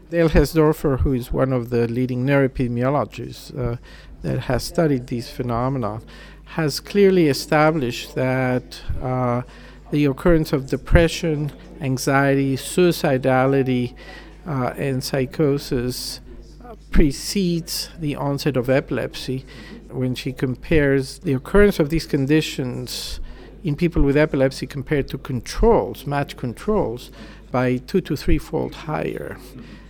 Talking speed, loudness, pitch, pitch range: 115 wpm, -21 LUFS, 140 Hz, 130-155 Hz